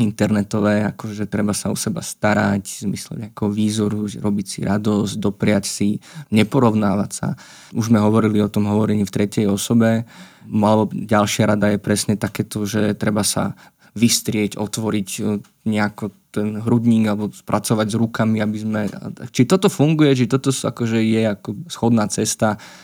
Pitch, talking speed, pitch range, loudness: 105 Hz, 150 wpm, 105-115 Hz, -19 LUFS